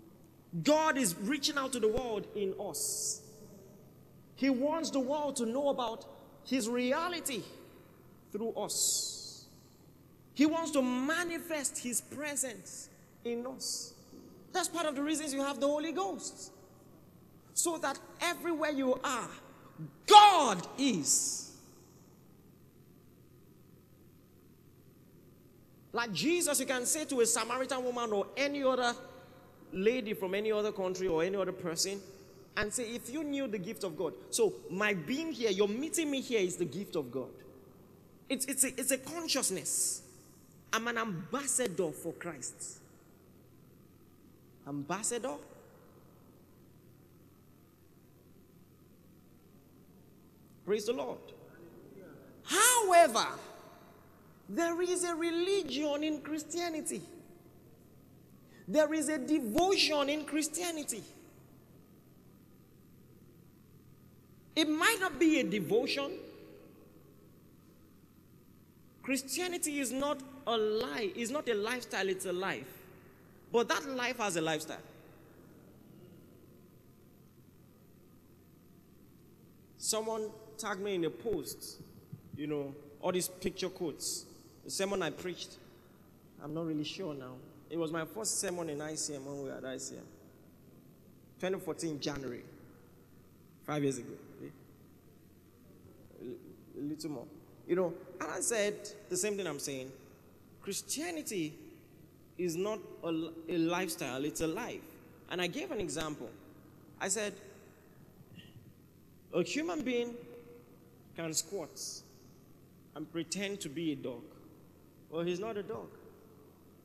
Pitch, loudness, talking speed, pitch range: 225 Hz, -33 LUFS, 115 wpm, 180-285 Hz